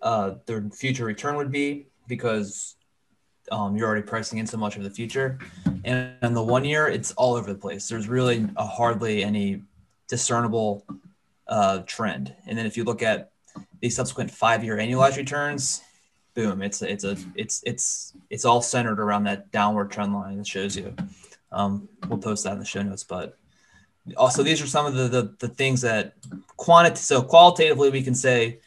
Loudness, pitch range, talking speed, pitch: -23 LUFS, 100-125 Hz, 185 wpm, 115 Hz